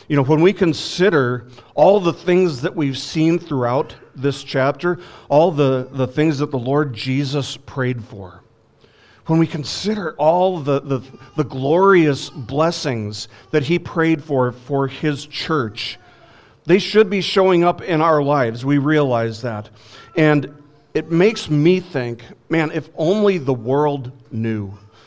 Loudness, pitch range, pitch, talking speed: -18 LUFS, 125-165 Hz, 145 Hz, 150 wpm